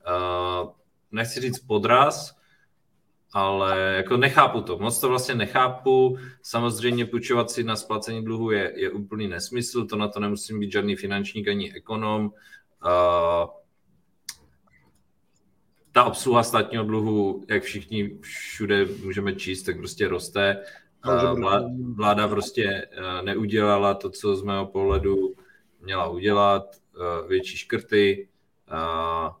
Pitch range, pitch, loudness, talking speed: 95-115 Hz, 105 Hz, -24 LUFS, 125 wpm